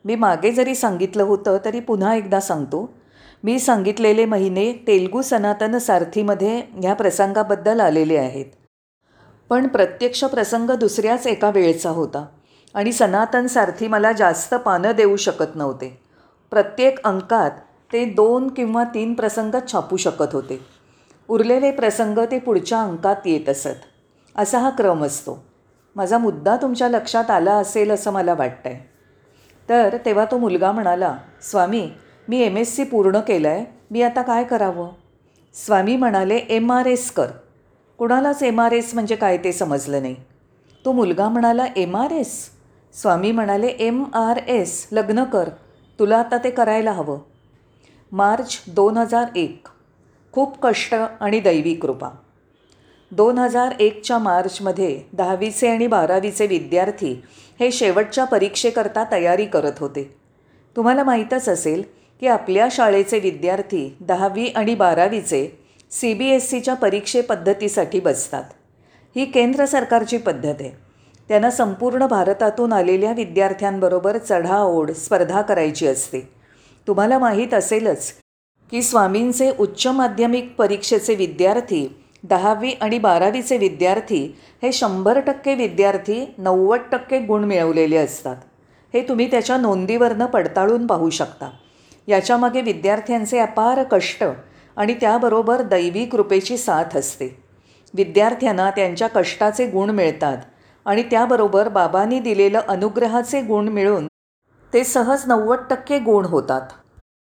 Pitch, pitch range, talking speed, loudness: 210 Hz, 185-240 Hz, 125 wpm, -19 LUFS